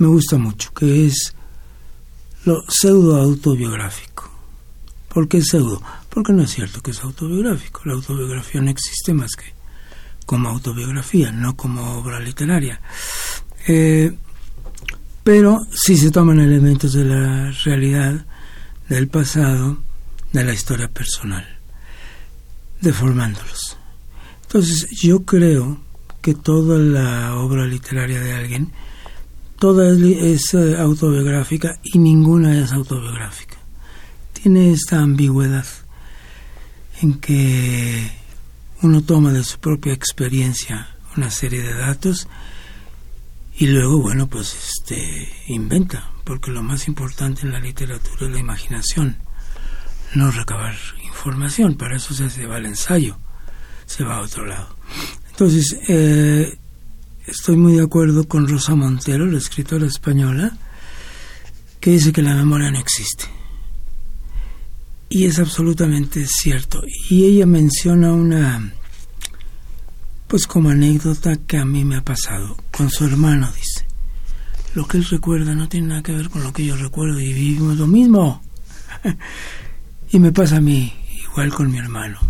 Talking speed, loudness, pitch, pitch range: 130 wpm, -17 LUFS, 135 Hz, 105-155 Hz